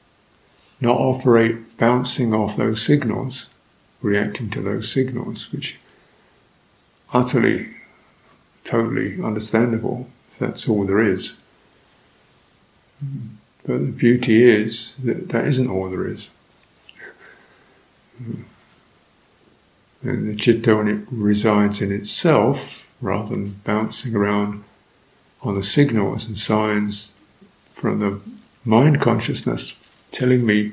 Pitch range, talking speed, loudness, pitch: 105-120 Hz, 100 wpm, -20 LUFS, 110 Hz